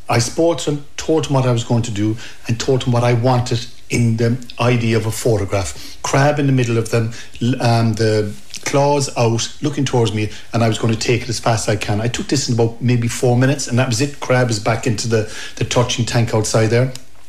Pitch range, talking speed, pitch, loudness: 115-125 Hz, 245 wpm, 120 Hz, -17 LUFS